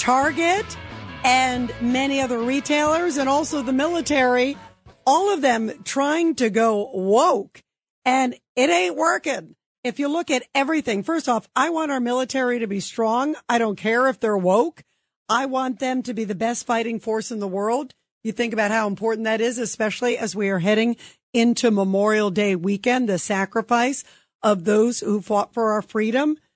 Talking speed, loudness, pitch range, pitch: 175 wpm, -21 LUFS, 220-265 Hz, 240 Hz